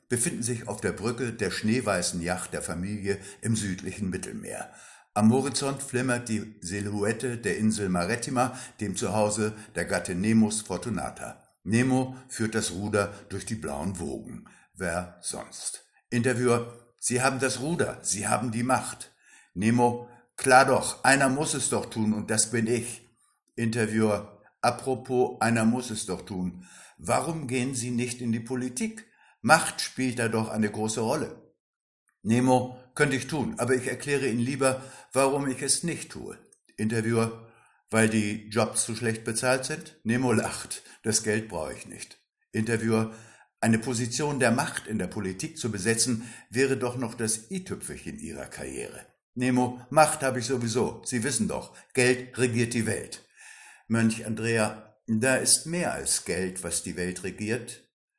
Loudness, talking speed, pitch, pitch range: -27 LUFS, 155 wpm, 115 Hz, 110-125 Hz